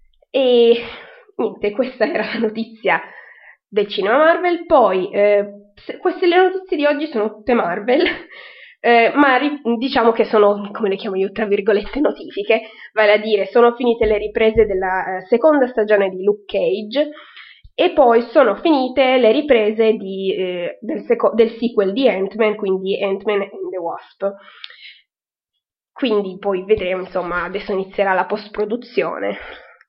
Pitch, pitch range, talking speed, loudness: 220 Hz, 200-255 Hz, 145 wpm, -17 LUFS